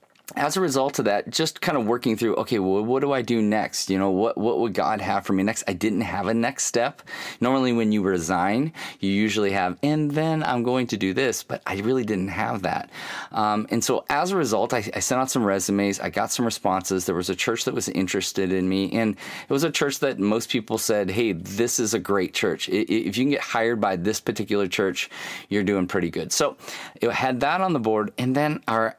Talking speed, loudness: 240 wpm, -24 LUFS